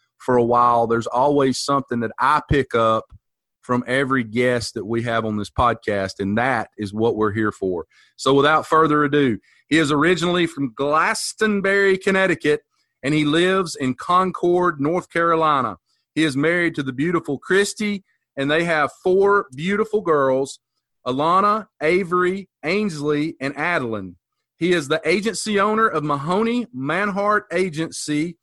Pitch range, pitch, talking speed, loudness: 130-180 Hz, 155 Hz, 150 wpm, -20 LUFS